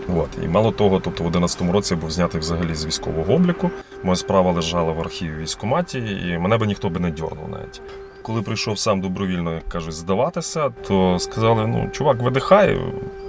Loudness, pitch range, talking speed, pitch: -21 LUFS, 85-110 Hz, 185 wpm, 95 Hz